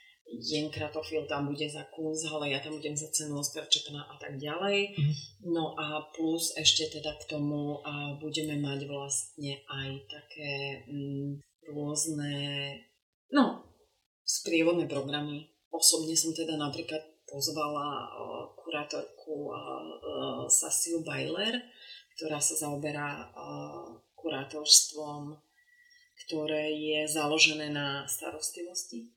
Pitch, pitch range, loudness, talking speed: 150 Hz, 145-155 Hz, -31 LUFS, 105 wpm